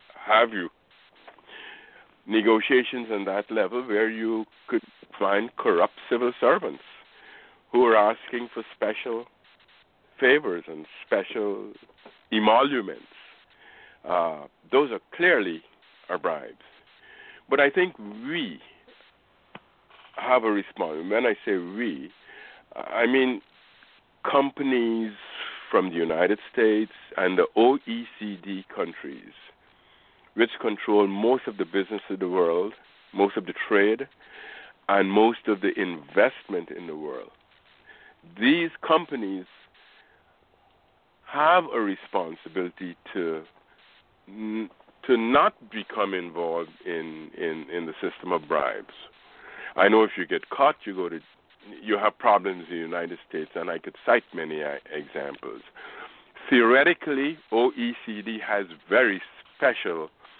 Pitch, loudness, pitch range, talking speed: 110 Hz, -25 LUFS, 95-135 Hz, 115 wpm